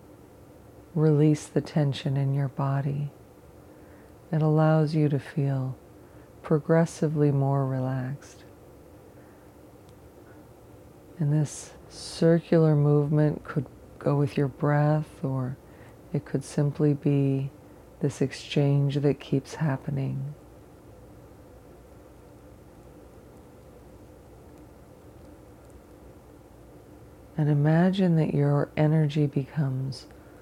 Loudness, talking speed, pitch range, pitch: -26 LUFS, 75 wpm, 135-150 Hz, 145 Hz